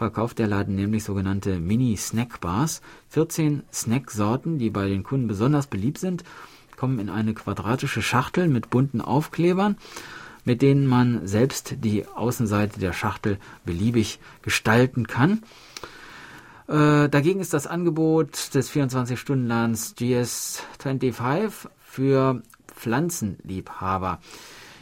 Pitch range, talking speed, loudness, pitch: 110-145 Hz, 110 wpm, -24 LUFS, 125 Hz